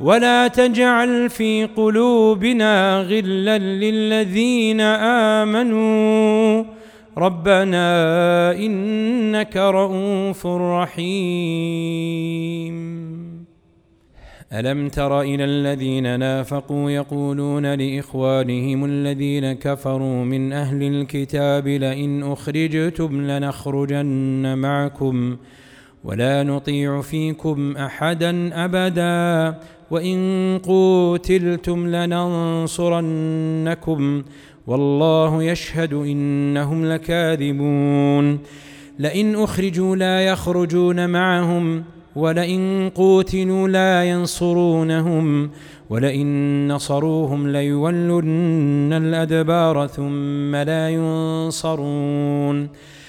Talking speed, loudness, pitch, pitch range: 60 wpm, -19 LUFS, 160 Hz, 145-185 Hz